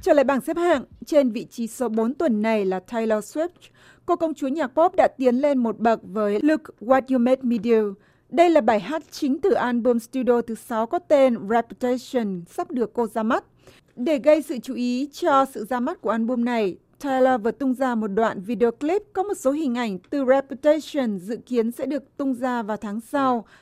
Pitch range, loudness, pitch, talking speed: 230-290 Hz, -23 LUFS, 250 Hz, 220 wpm